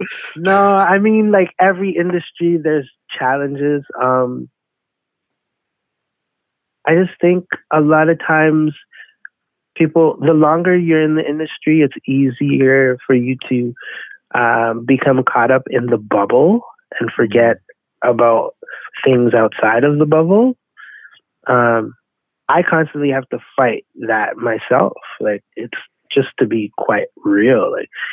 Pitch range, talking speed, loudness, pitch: 130-175 Hz, 125 wpm, -15 LUFS, 150 Hz